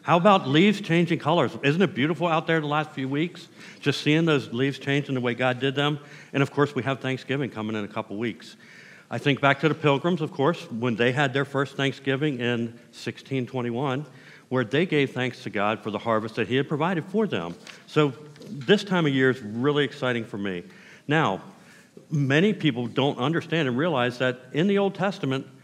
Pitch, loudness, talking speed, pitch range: 140 Hz, -25 LUFS, 205 wpm, 125-160 Hz